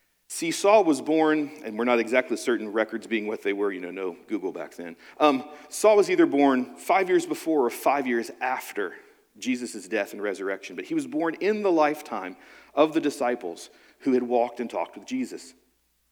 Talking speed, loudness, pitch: 195 wpm, -25 LUFS, 150 Hz